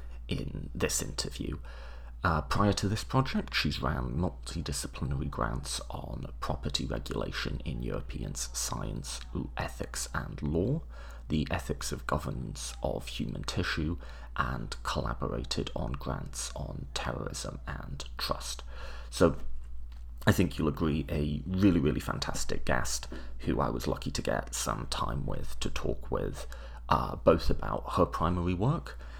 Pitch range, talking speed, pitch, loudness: 60-80 Hz, 130 wpm, 65 Hz, -33 LUFS